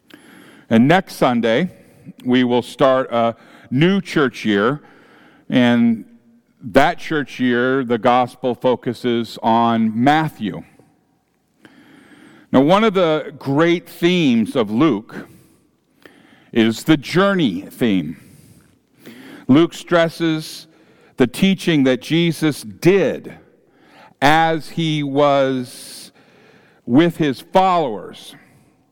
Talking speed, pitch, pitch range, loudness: 90 wpm, 155 Hz, 125-180 Hz, -17 LUFS